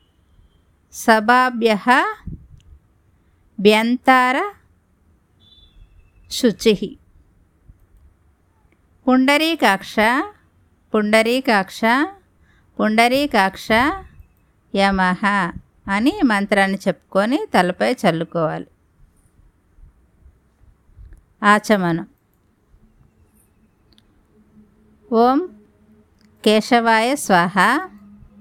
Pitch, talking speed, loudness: 180 Hz, 30 wpm, -17 LUFS